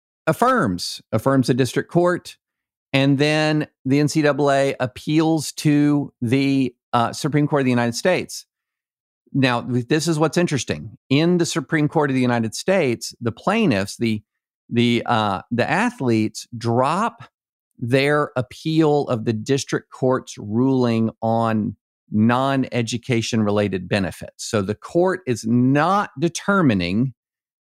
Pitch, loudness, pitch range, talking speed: 130 Hz, -20 LUFS, 115-150 Hz, 125 wpm